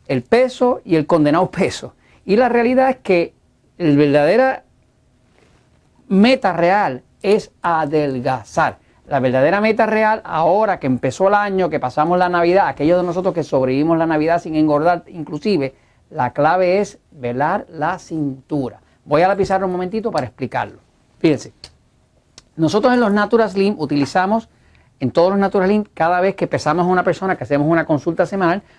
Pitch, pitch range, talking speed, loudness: 175 Hz, 150-195 Hz, 160 wpm, -17 LUFS